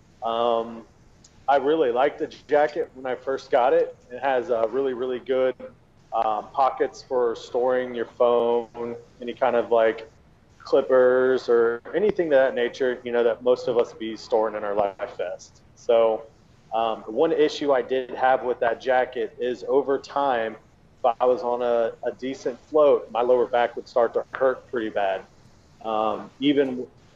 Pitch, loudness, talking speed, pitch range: 125 Hz, -24 LUFS, 170 wpm, 115-135 Hz